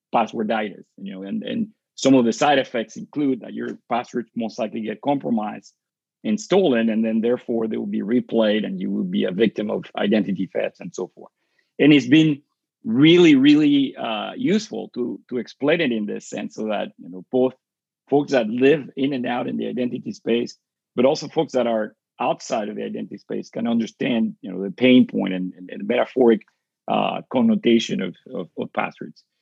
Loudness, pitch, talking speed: -21 LUFS, 130 Hz, 190 wpm